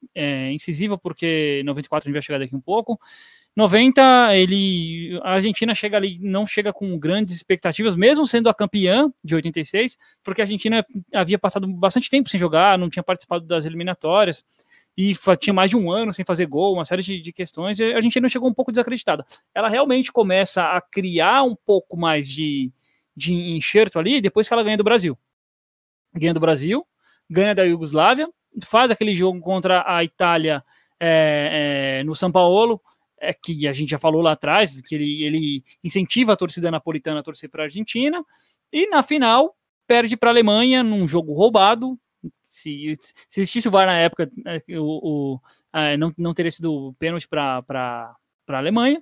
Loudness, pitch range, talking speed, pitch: -19 LUFS, 160-220 Hz, 180 wpm, 185 Hz